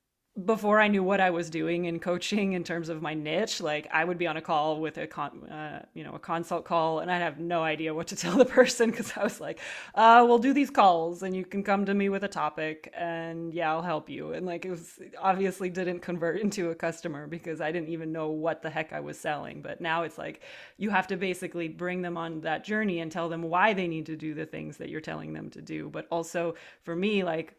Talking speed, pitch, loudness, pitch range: 260 wpm, 170 Hz, -28 LUFS, 160-190 Hz